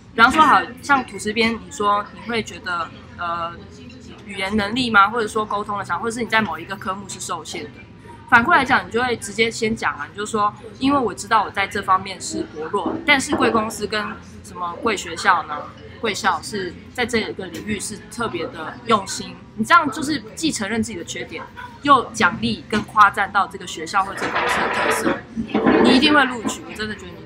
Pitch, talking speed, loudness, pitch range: 215 Hz, 305 characters per minute, -20 LUFS, 195-235 Hz